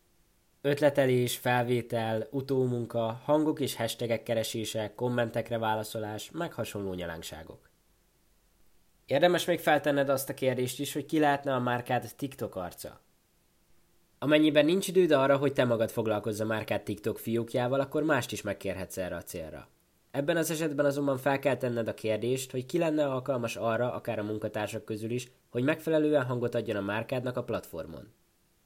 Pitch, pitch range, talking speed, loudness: 125 Hz, 110-140 Hz, 150 wpm, -30 LUFS